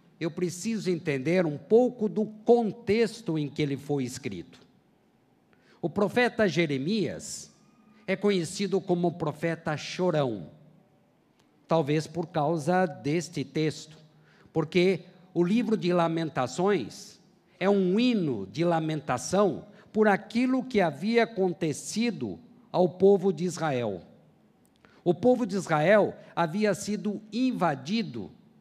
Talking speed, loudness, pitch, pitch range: 110 wpm, -27 LUFS, 180 Hz, 160-205 Hz